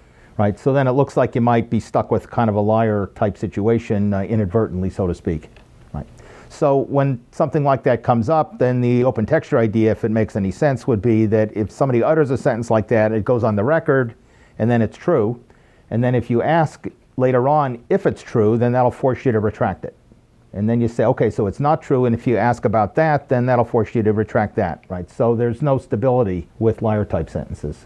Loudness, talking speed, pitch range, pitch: -19 LUFS, 230 wpm, 110-130 Hz, 115 Hz